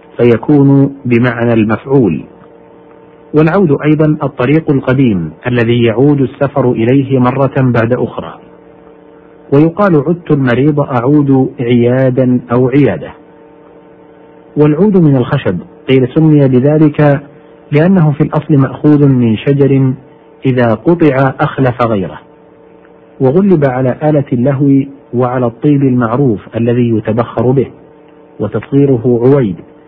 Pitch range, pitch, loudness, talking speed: 125-150 Hz, 140 Hz, -10 LUFS, 100 wpm